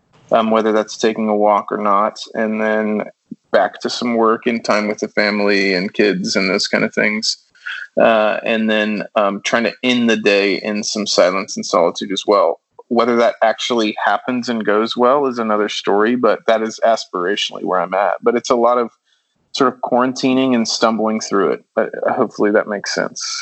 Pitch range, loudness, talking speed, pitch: 105-120 Hz, -16 LUFS, 195 wpm, 110 Hz